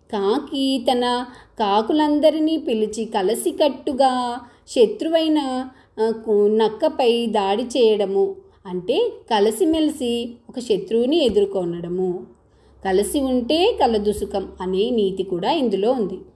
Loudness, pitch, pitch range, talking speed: -20 LUFS, 240 Hz, 210-300 Hz, 80 wpm